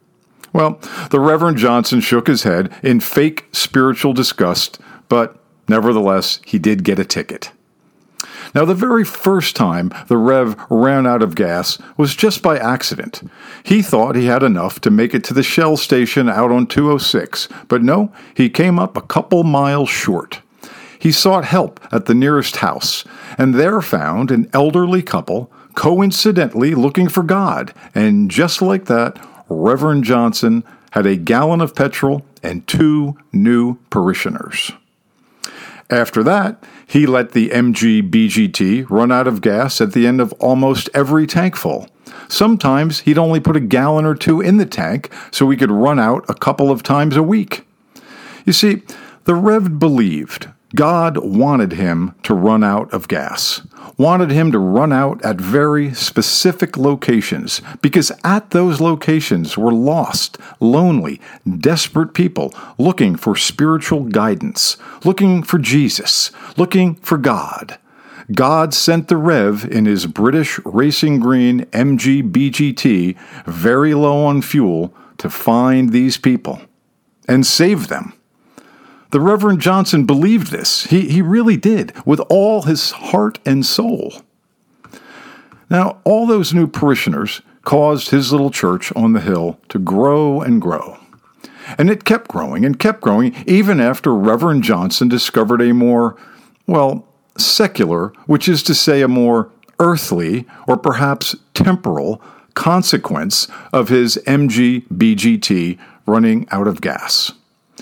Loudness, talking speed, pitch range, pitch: -14 LUFS, 145 wpm, 130-195 Hz, 155 Hz